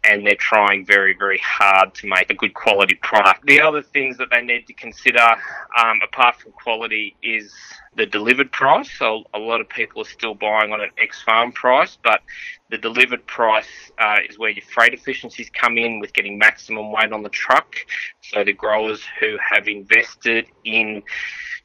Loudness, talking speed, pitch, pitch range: -17 LUFS, 185 wpm, 110 Hz, 105-125 Hz